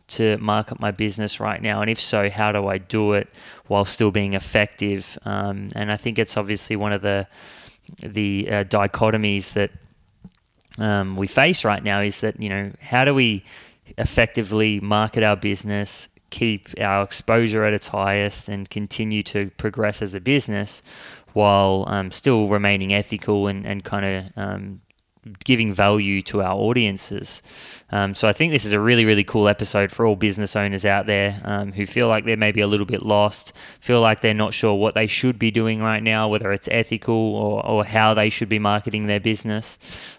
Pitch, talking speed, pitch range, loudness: 105 Hz, 190 wpm, 100-110 Hz, -21 LUFS